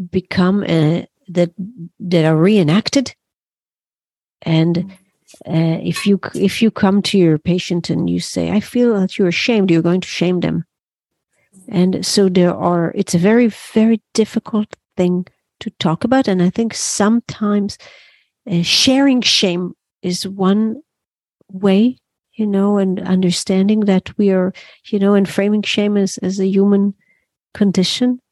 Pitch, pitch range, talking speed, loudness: 195 Hz, 180-210 Hz, 150 wpm, -16 LUFS